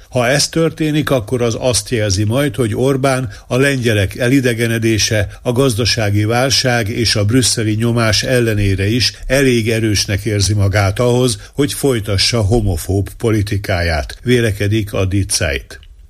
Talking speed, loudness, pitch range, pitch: 125 wpm, -15 LUFS, 100-125 Hz, 115 Hz